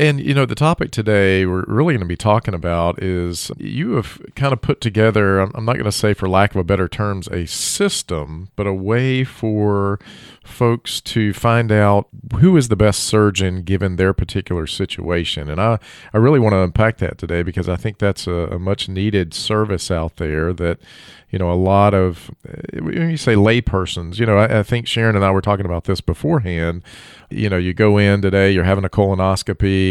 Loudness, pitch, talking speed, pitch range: -17 LUFS, 100 Hz, 205 wpm, 90-110 Hz